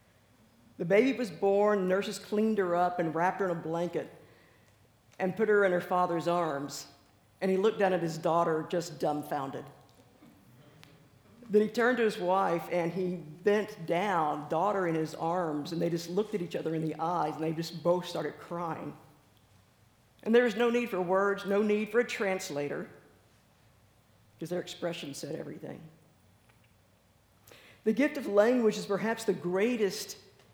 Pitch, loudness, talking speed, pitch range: 170 Hz, -30 LUFS, 165 wpm, 145-200 Hz